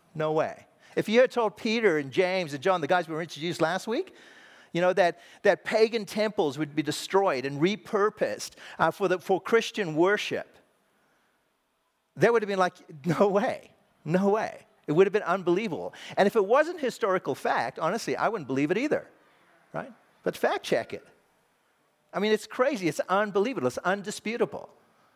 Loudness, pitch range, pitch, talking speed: -27 LUFS, 175-220 Hz, 195 Hz, 175 wpm